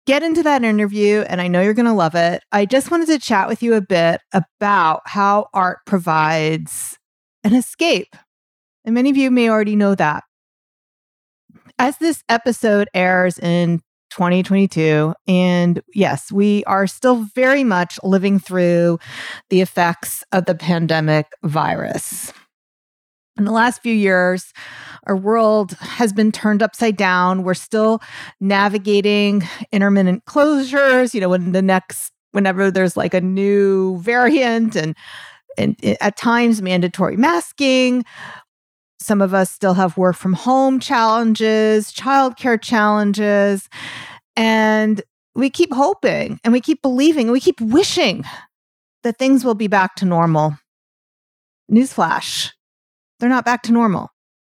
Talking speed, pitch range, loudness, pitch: 140 wpm, 185-235 Hz, -16 LUFS, 205 Hz